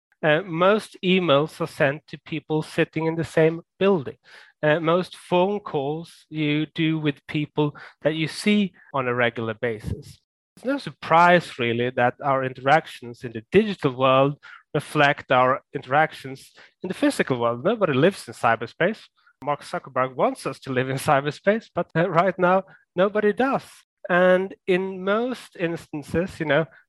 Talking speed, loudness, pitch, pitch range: 155 wpm, -23 LUFS, 160 Hz, 140-185 Hz